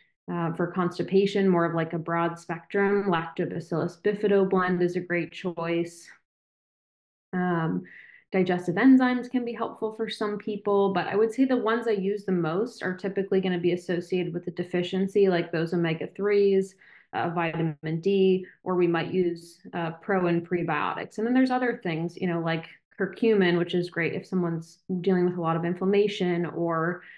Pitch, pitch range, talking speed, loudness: 180 Hz, 170-200 Hz, 175 wpm, -26 LUFS